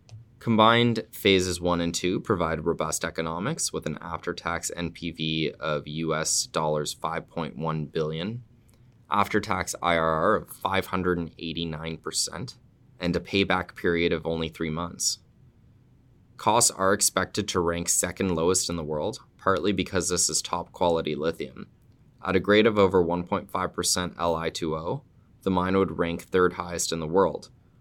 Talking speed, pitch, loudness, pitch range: 135 wpm, 85 Hz, -26 LUFS, 80-95 Hz